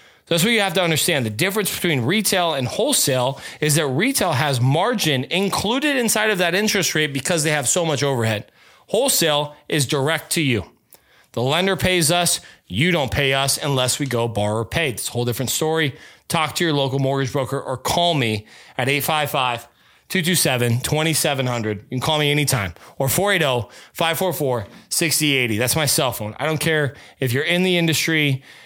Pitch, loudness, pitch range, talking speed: 150 Hz, -19 LUFS, 130-175 Hz, 180 wpm